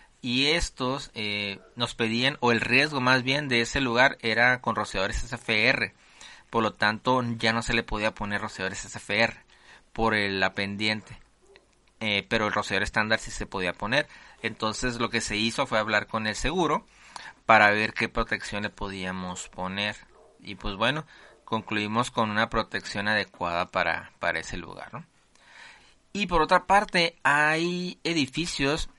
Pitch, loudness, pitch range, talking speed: 115 Hz, -26 LUFS, 105-130 Hz, 155 wpm